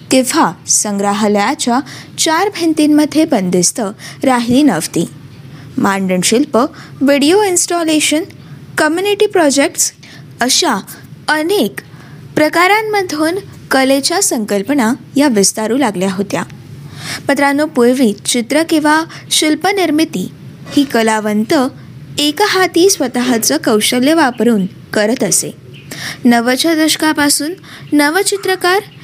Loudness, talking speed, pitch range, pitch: -13 LUFS, 75 wpm, 225-320 Hz, 280 Hz